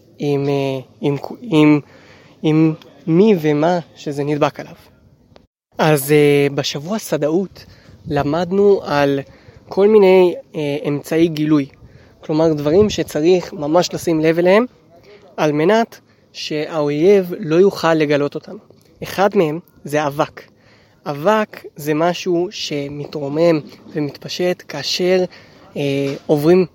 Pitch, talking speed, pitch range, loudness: 155 Hz, 100 wpm, 145-180 Hz, -17 LUFS